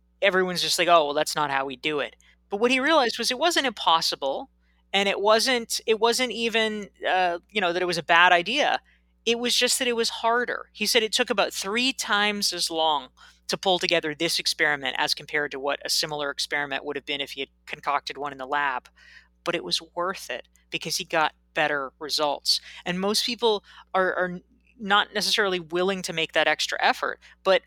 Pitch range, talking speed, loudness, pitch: 155-220 Hz, 210 wpm, -24 LUFS, 180 Hz